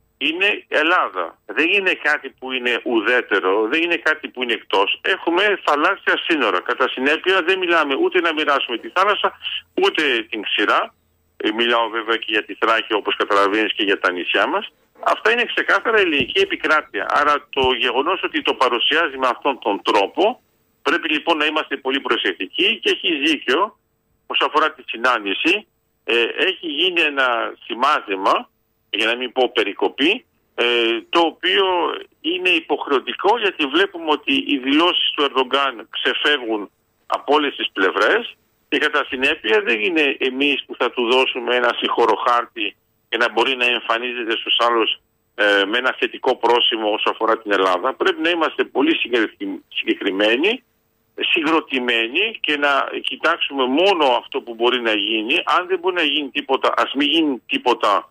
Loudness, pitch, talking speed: -18 LUFS, 170 Hz, 155 wpm